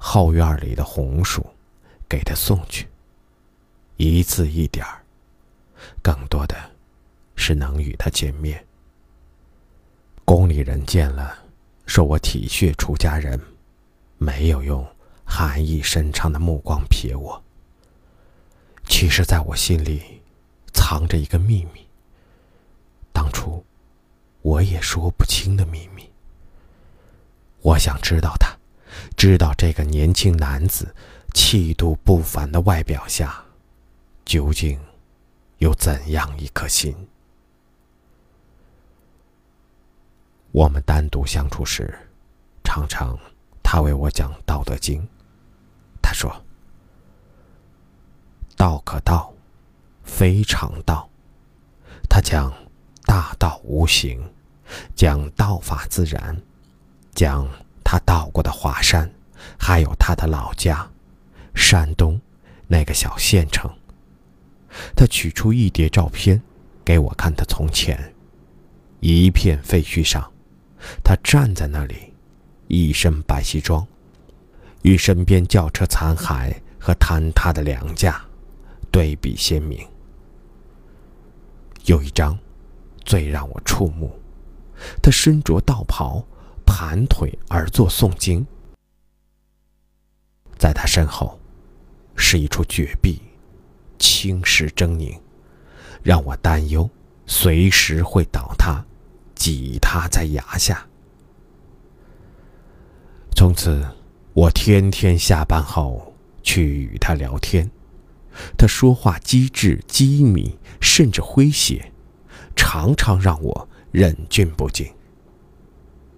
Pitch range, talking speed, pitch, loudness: 70-90 Hz, 145 characters per minute, 80 Hz, -19 LUFS